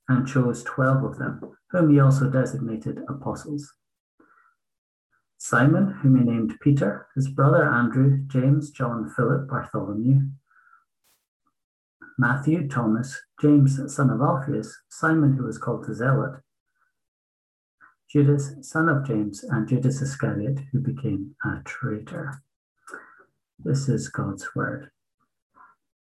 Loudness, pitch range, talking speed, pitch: -23 LUFS, 120-145 Hz, 115 wpm, 135 Hz